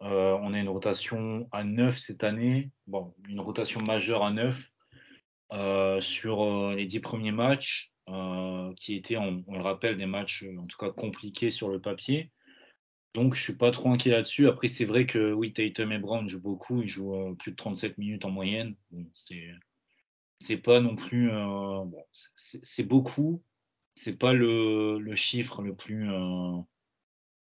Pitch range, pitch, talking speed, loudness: 95-120 Hz, 105 Hz, 180 wpm, -29 LUFS